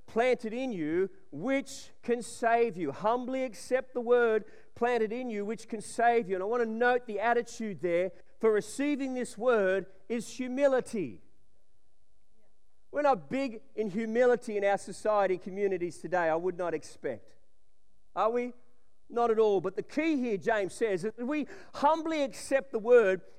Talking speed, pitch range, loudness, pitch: 165 wpm, 200-250 Hz, -30 LUFS, 230 Hz